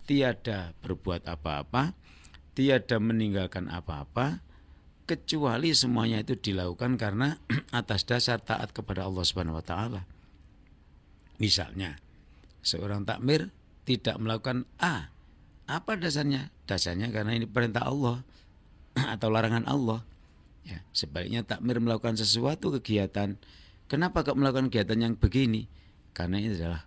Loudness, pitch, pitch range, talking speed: -29 LUFS, 110 Hz, 85-120 Hz, 115 wpm